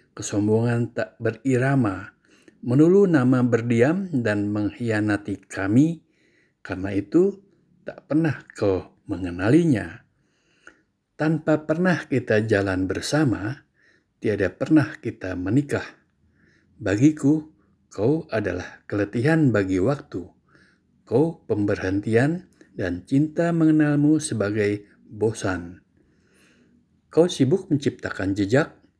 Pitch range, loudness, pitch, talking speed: 100-150 Hz, -23 LUFS, 120 Hz, 85 wpm